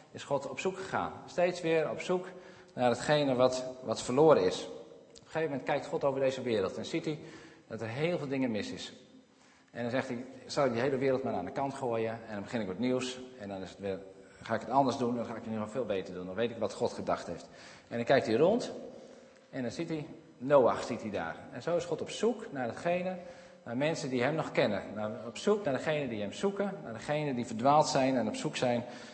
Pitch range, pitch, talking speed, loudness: 120-160 Hz, 135 Hz, 255 wpm, -32 LUFS